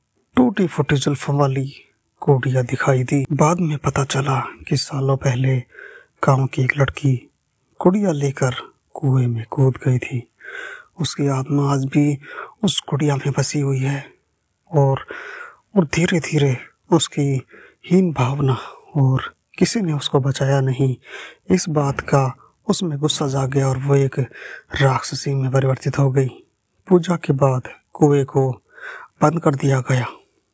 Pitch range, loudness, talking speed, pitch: 135-150 Hz, -19 LUFS, 140 wpm, 140 Hz